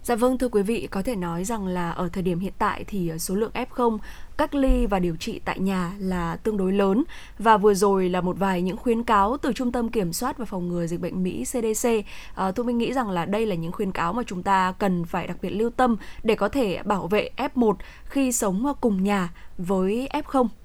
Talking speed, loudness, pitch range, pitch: 240 wpm, -24 LUFS, 185-240 Hz, 205 Hz